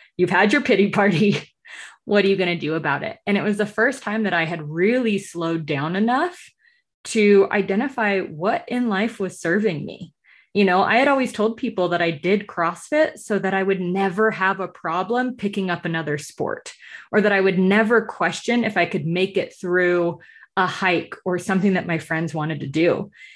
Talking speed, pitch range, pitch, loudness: 205 wpm, 175-220 Hz, 195 Hz, -21 LUFS